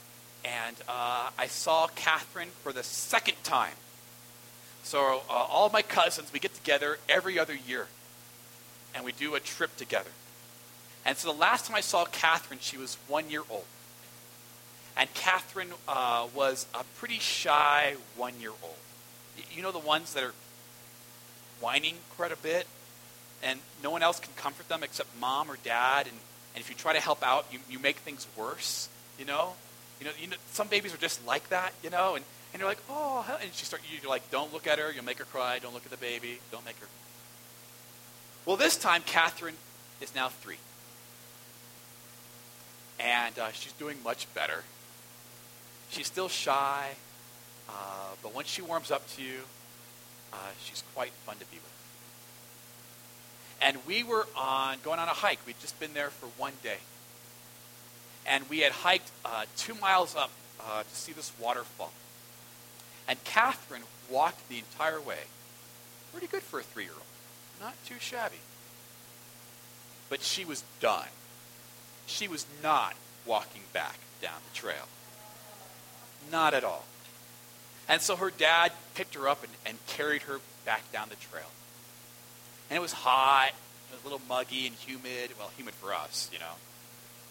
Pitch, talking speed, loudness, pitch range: 130 Hz, 170 wpm, -31 LUFS, 120-155 Hz